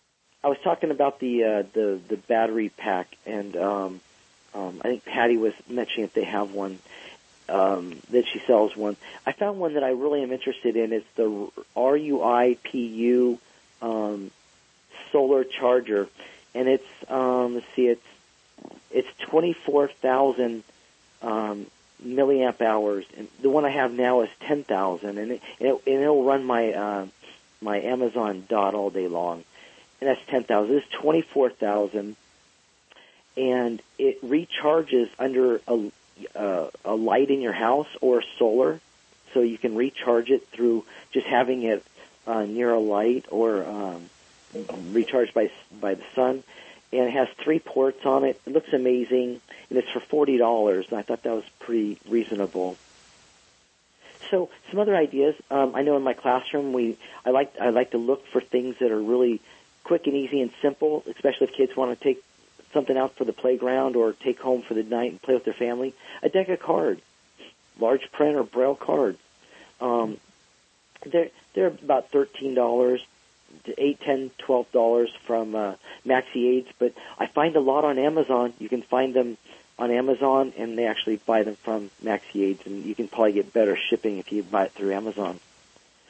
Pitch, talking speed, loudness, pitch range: 120 Hz, 175 wpm, -25 LUFS, 110-135 Hz